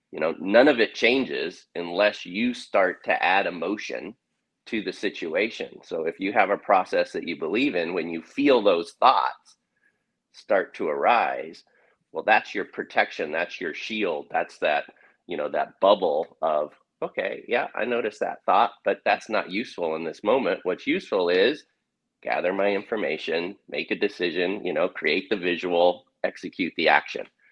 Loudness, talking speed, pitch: -25 LUFS, 170 wpm, 400 Hz